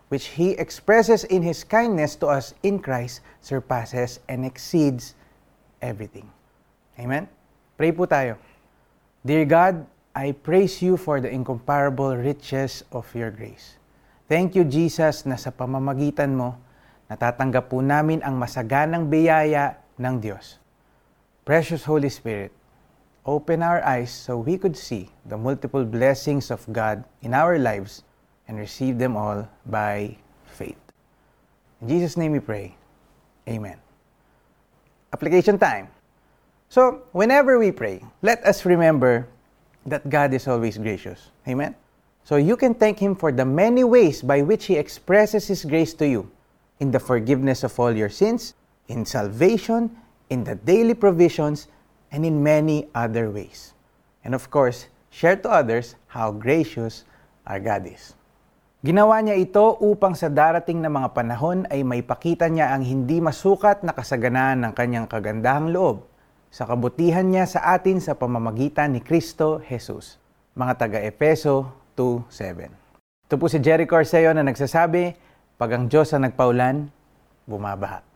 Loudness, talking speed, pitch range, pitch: -21 LUFS, 140 wpm, 125-165 Hz, 140 Hz